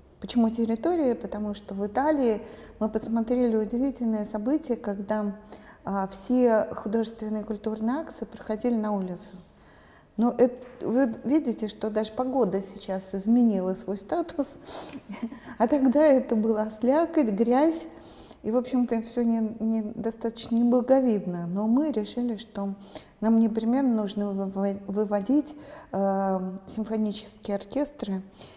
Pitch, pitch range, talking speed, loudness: 225 Hz, 205-250 Hz, 120 wpm, -27 LUFS